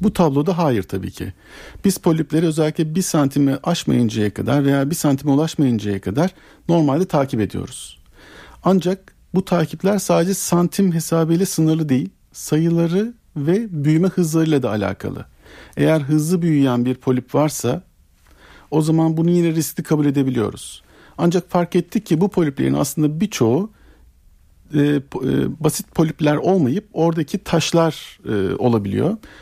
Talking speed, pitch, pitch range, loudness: 125 wpm, 155 Hz, 130-175 Hz, -19 LUFS